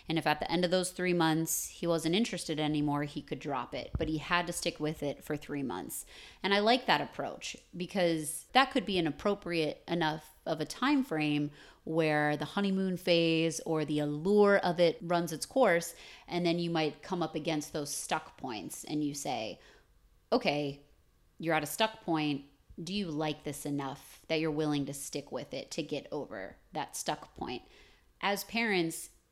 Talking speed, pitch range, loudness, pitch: 190 wpm, 150-180 Hz, -32 LUFS, 160 Hz